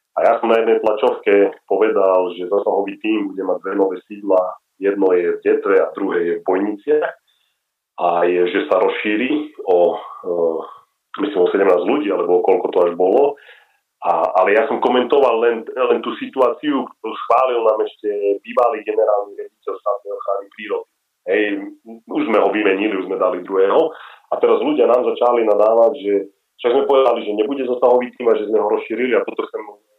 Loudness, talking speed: -17 LUFS, 180 wpm